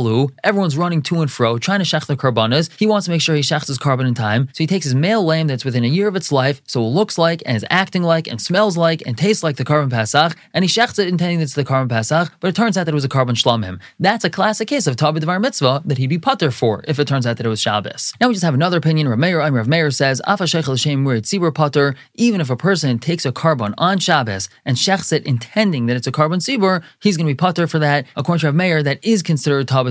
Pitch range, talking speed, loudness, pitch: 130-180 Hz, 275 wpm, -17 LUFS, 155 Hz